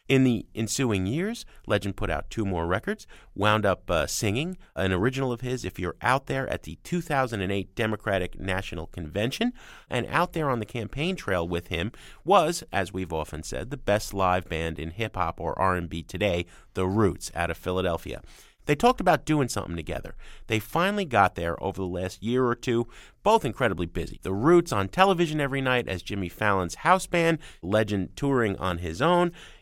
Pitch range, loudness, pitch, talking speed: 90-130 Hz, -27 LUFS, 100 Hz, 185 wpm